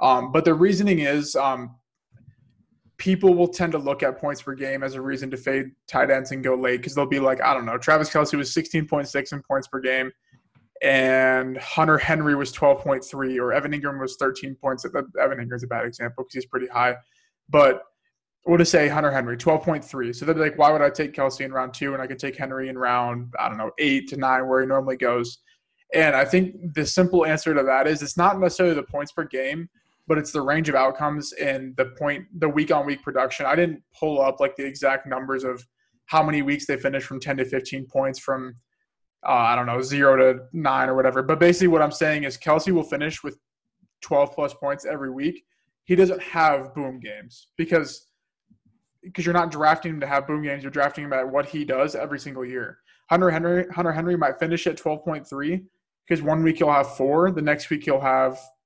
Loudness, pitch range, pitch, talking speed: -22 LUFS, 130-160 Hz, 140 Hz, 220 wpm